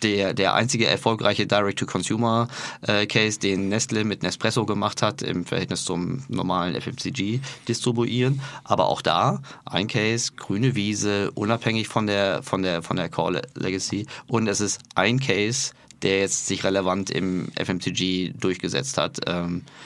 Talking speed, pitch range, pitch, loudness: 140 wpm, 95-120 Hz, 105 Hz, -24 LUFS